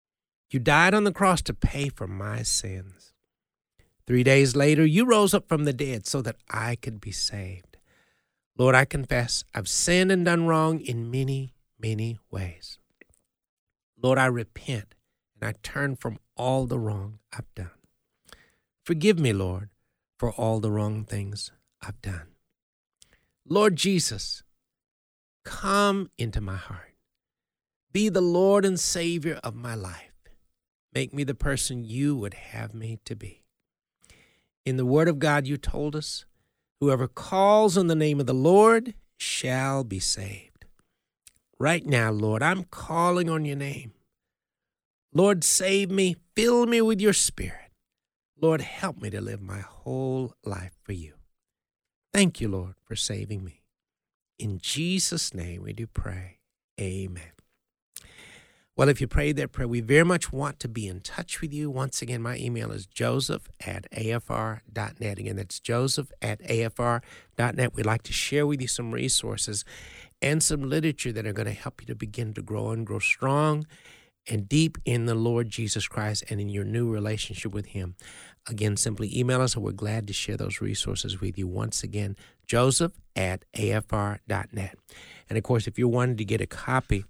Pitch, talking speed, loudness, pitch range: 120 Hz, 165 wpm, -26 LUFS, 105-145 Hz